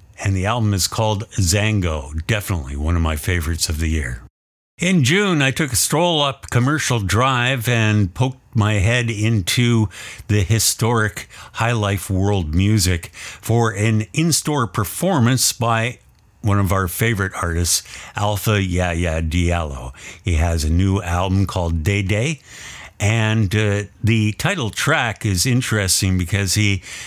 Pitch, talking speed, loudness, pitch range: 105 Hz, 145 wpm, -19 LUFS, 90-115 Hz